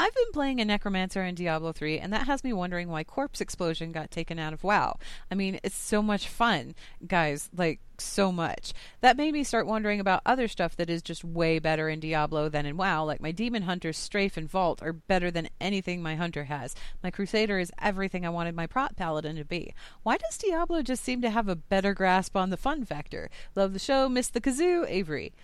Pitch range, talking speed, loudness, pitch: 160-220 Hz, 225 wpm, -29 LUFS, 185 Hz